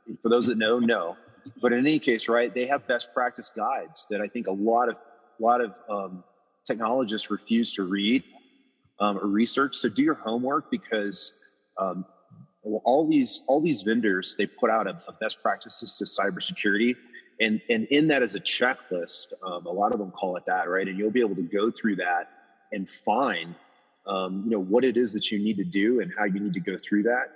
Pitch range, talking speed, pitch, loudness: 100-125 Hz, 215 wpm, 110 Hz, -26 LUFS